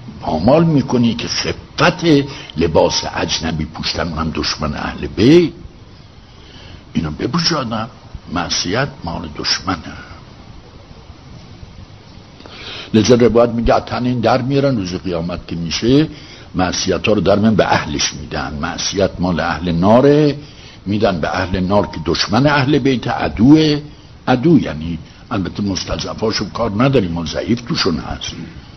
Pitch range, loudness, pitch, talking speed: 85-130 Hz, -16 LUFS, 105 Hz, 120 wpm